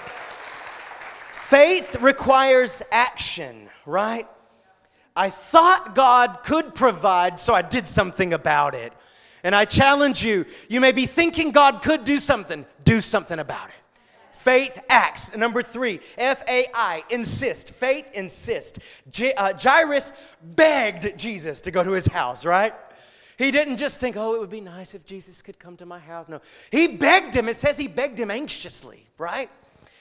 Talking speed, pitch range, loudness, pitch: 160 wpm, 190-275 Hz, -20 LUFS, 245 Hz